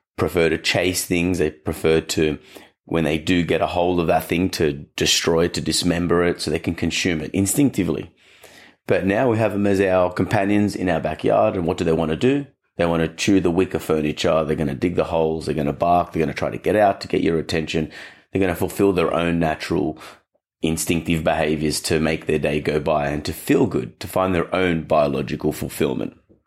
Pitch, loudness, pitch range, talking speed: 85 Hz, -21 LUFS, 80-95 Hz, 225 wpm